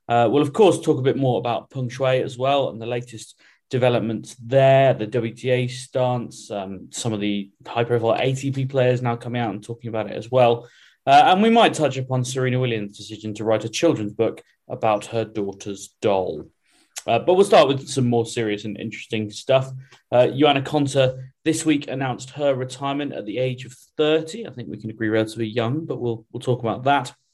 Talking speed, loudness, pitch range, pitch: 200 wpm, -21 LUFS, 115-135 Hz, 125 Hz